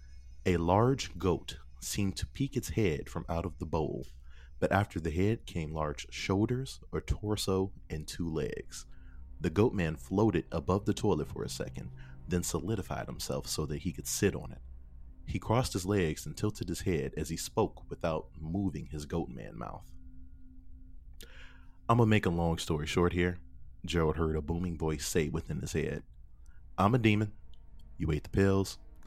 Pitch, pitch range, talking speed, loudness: 85 Hz, 70-95 Hz, 180 wpm, -33 LUFS